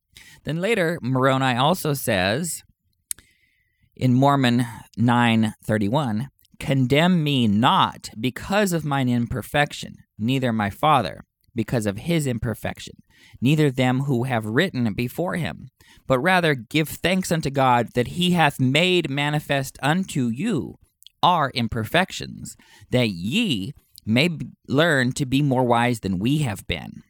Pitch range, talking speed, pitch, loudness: 115-150 Hz, 125 wpm, 130 Hz, -22 LUFS